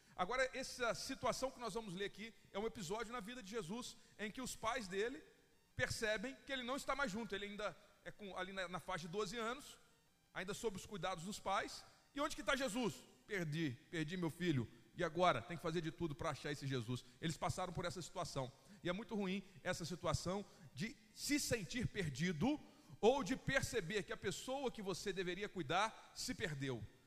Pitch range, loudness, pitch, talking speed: 170-230 Hz, -43 LUFS, 195 Hz, 200 wpm